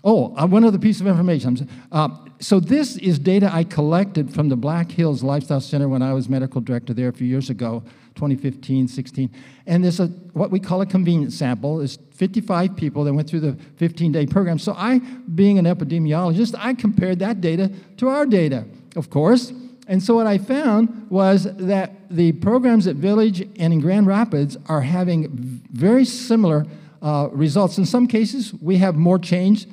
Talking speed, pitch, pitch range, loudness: 185 wpm, 175 Hz, 145-200 Hz, -19 LUFS